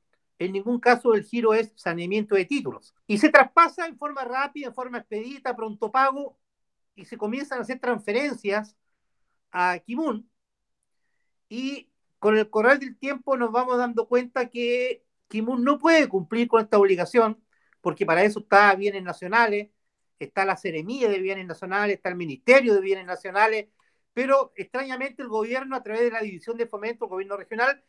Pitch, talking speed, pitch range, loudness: 230 Hz, 170 wpm, 205-260 Hz, -24 LUFS